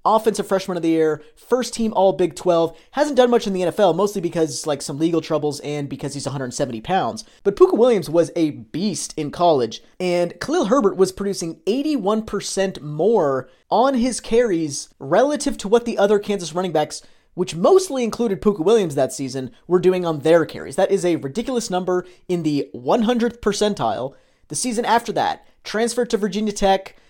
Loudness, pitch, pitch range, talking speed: -20 LUFS, 190 Hz, 165-230 Hz, 180 wpm